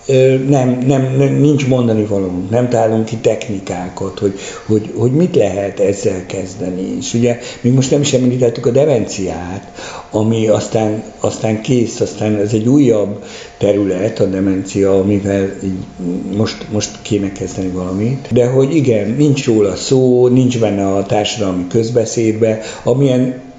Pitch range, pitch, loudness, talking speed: 100-125 Hz, 110 Hz, -14 LUFS, 140 wpm